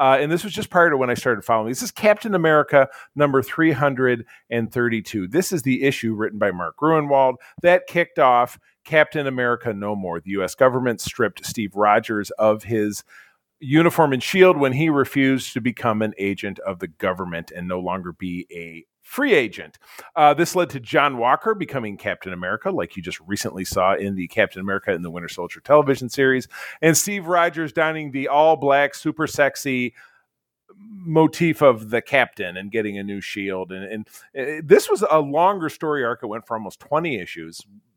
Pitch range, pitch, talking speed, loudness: 105-155 Hz, 130 Hz, 185 wpm, -20 LUFS